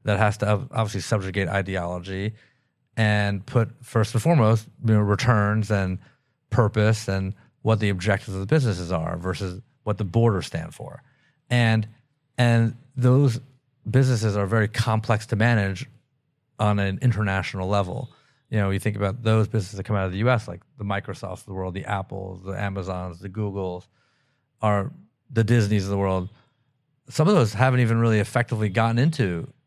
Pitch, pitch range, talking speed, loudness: 110 Hz, 100-125 Hz, 170 wpm, -24 LUFS